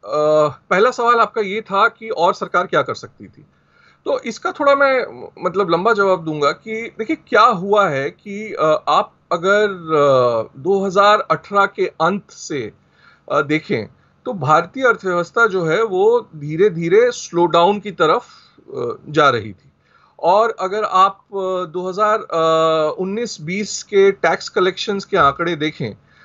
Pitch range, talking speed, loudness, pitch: 165-220 Hz, 145 wpm, -17 LUFS, 195 Hz